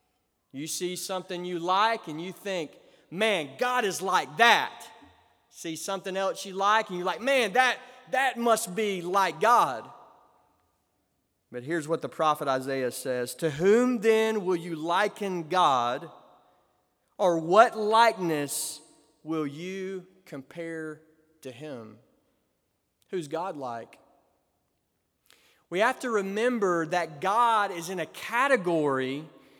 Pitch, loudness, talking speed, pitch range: 180 Hz, -27 LUFS, 130 wpm, 155-215 Hz